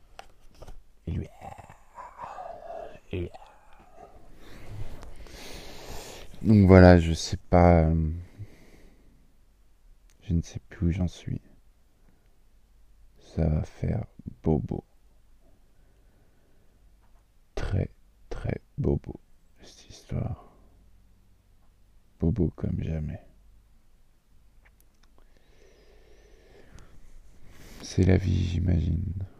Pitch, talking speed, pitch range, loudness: 95 Hz, 70 wpm, 85-100 Hz, -26 LUFS